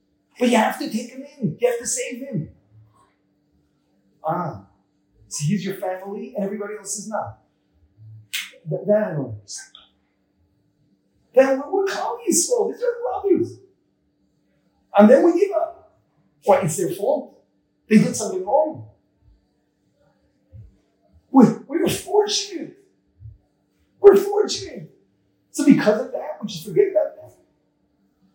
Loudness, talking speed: -20 LUFS, 125 wpm